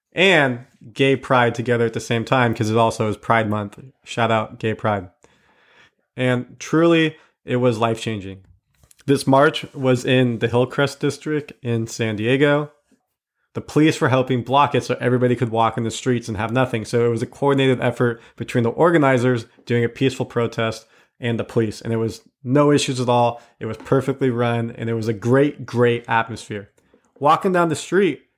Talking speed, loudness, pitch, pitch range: 185 wpm, -19 LUFS, 120 Hz, 115-135 Hz